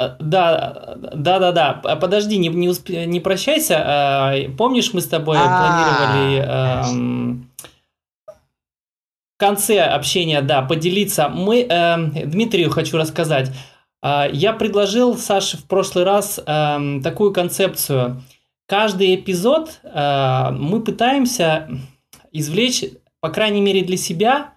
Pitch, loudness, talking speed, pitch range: 170 Hz, -17 LUFS, 95 wpm, 145-200 Hz